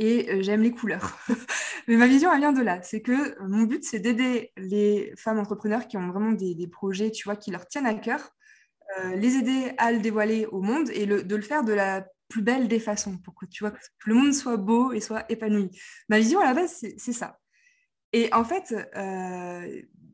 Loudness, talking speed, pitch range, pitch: -25 LUFS, 225 wpm, 205-245 Hz, 220 Hz